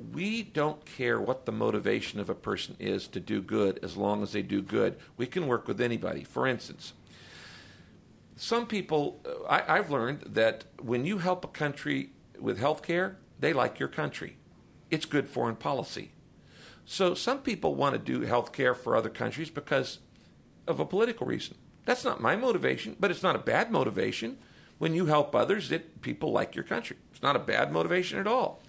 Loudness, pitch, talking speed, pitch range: -30 LUFS, 145 Hz, 190 wpm, 110-180 Hz